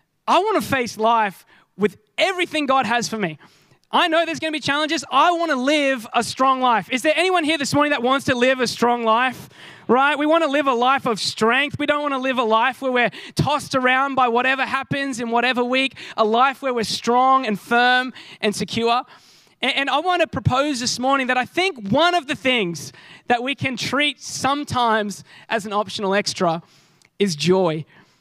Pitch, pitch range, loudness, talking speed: 255 Hz, 225-280 Hz, -19 LUFS, 195 wpm